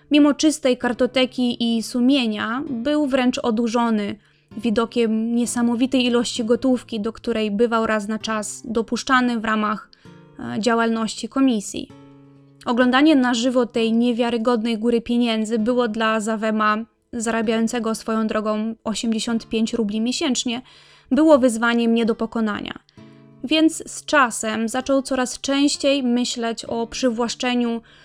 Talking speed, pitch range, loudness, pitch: 115 wpm, 225-255 Hz, -20 LUFS, 235 Hz